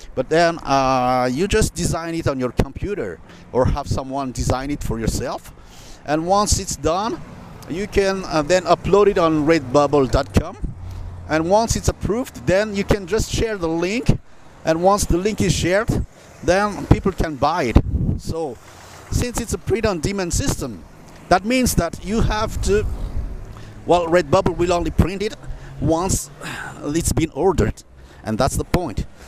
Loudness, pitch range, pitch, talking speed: -20 LUFS, 125-185 Hz, 160 Hz, 160 wpm